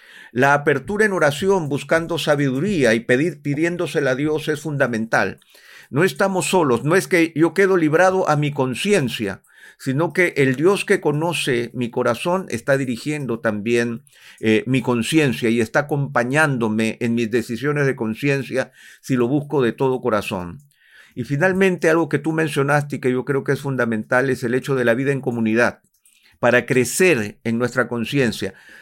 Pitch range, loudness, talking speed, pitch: 120-160 Hz, -19 LUFS, 165 wpm, 140 Hz